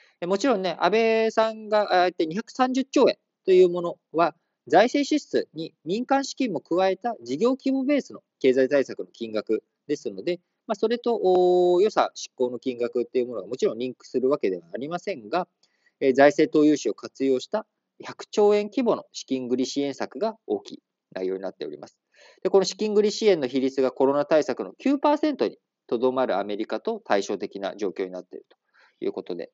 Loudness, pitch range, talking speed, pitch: -24 LUFS, 140-235 Hz, 345 characters per minute, 185 Hz